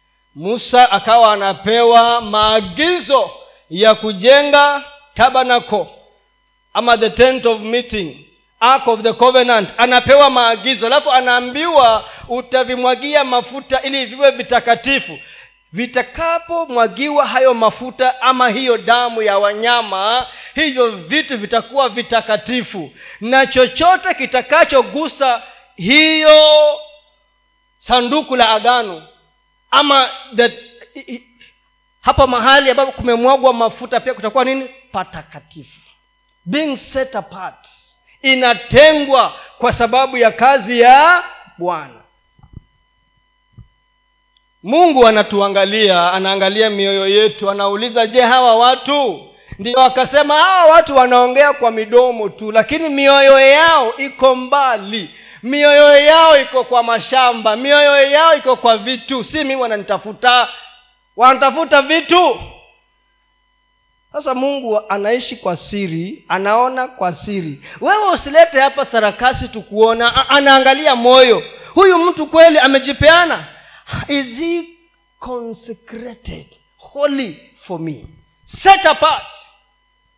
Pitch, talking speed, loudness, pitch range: 255 Hz, 95 wpm, -12 LUFS, 230-290 Hz